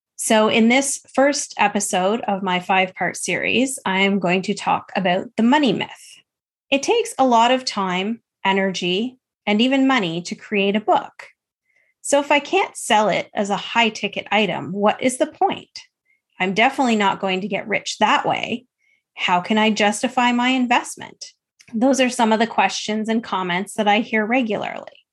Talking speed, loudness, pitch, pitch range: 180 wpm, -19 LUFS, 220 Hz, 195-260 Hz